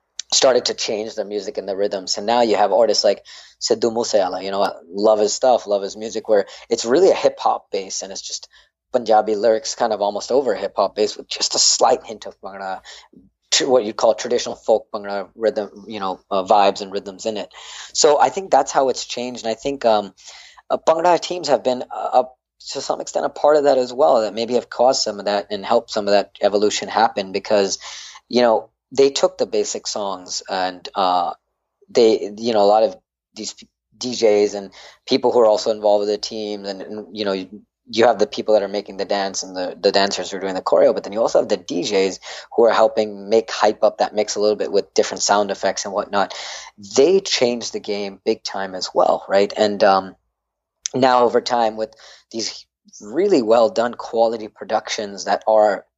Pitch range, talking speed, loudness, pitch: 100-125 Hz, 220 wpm, -19 LUFS, 110 Hz